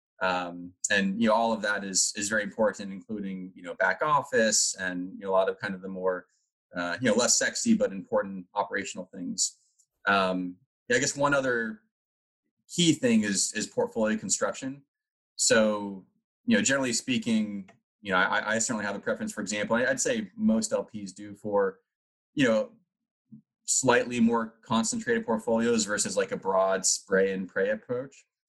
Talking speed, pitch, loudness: 175 wpm, 115 Hz, -27 LUFS